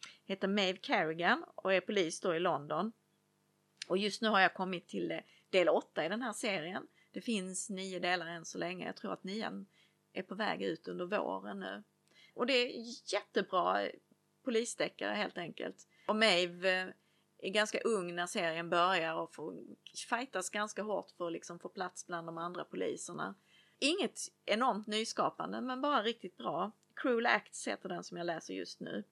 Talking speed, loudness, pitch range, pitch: 175 wpm, -36 LUFS, 180-225 Hz, 195 Hz